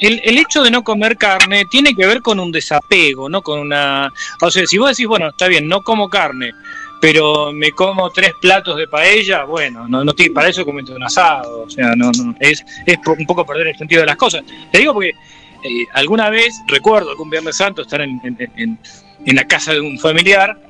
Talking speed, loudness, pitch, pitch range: 225 wpm, -12 LUFS, 185 Hz, 150-215 Hz